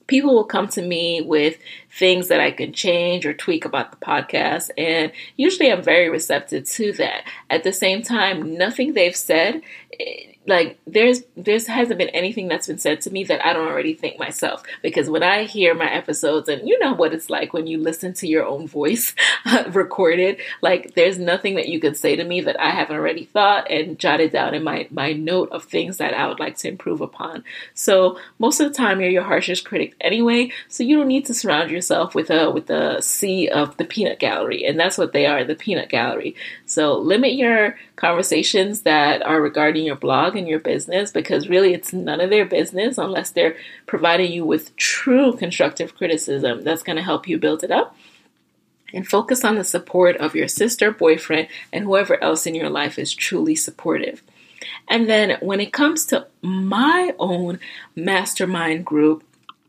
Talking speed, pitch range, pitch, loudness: 195 wpm, 165-230 Hz, 185 Hz, -19 LUFS